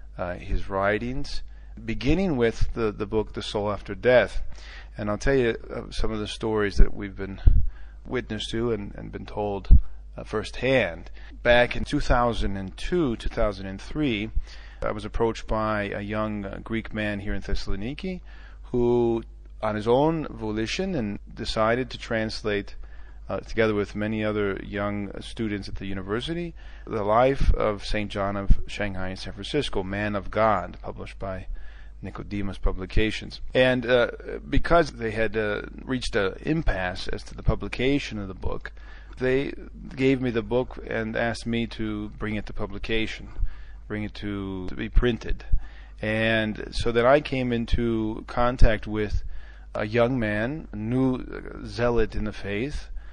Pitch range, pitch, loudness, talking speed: 100-115 Hz, 105 Hz, -27 LUFS, 155 wpm